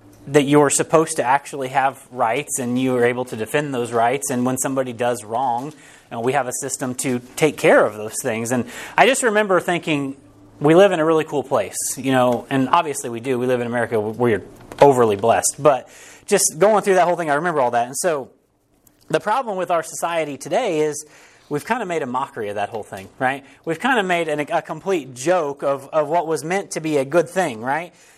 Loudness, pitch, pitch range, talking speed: -19 LUFS, 140 Hz, 125-165 Hz, 240 wpm